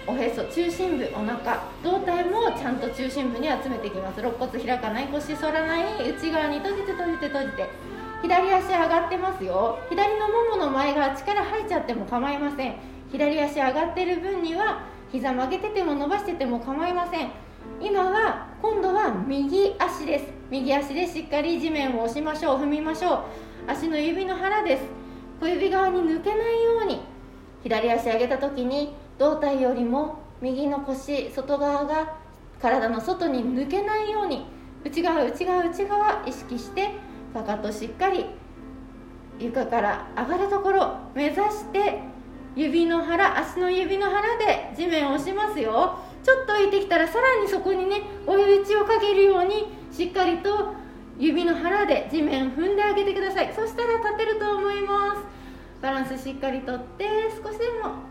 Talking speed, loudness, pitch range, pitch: 320 characters per minute, -25 LUFS, 275-395 Hz, 335 Hz